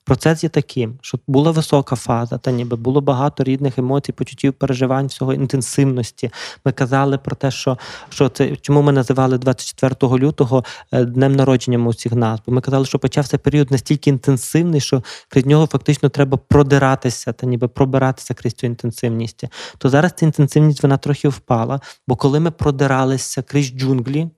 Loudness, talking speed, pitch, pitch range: -17 LUFS, 160 wpm, 135 Hz, 130-145 Hz